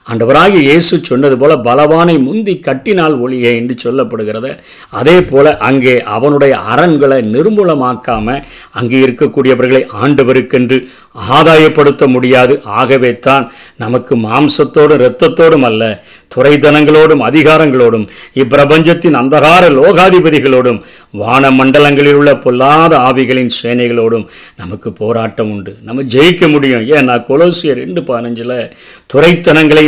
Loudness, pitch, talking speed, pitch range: -8 LUFS, 135 Hz, 95 wpm, 125-155 Hz